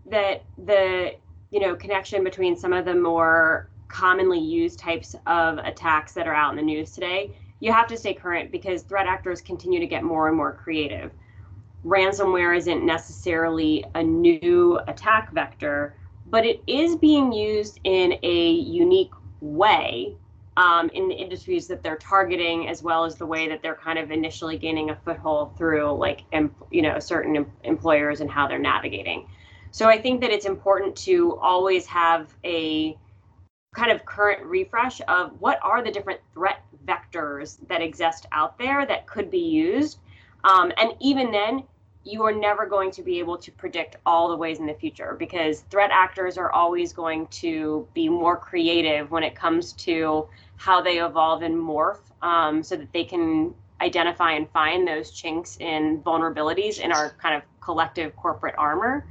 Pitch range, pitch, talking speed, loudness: 155-210 Hz, 170 Hz, 175 wpm, -23 LUFS